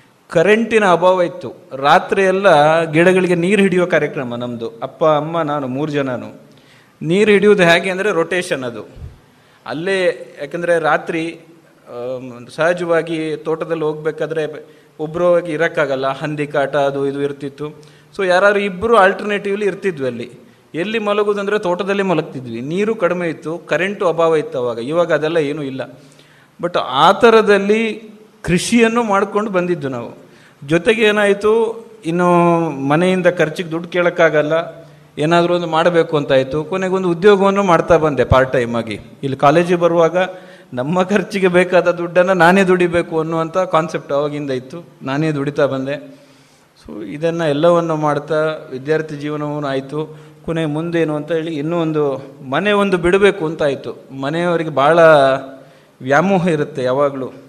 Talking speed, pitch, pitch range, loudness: 120 wpm, 165 Hz, 145-180 Hz, -16 LUFS